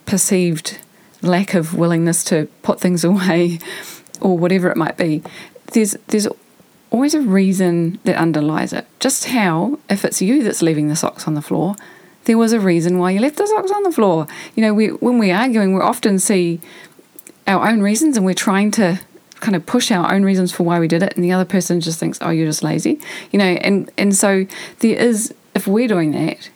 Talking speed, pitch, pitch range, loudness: 210 wpm, 195 Hz, 175-220 Hz, -16 LUFS